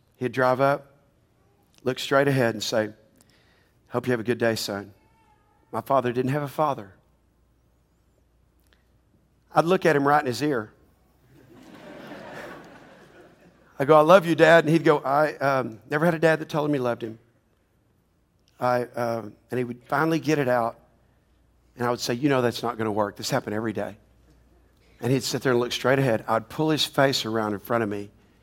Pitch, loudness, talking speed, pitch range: 120 Hz, -24 LUFS, 190 wpm, 110-140 Hz